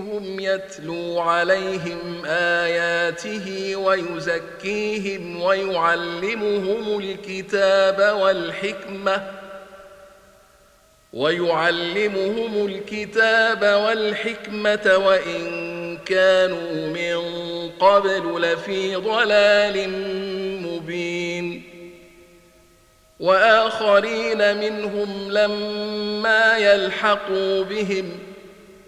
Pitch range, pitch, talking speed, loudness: 175-205 Hz, 195 Hz, 45 wpm, -21 LUFS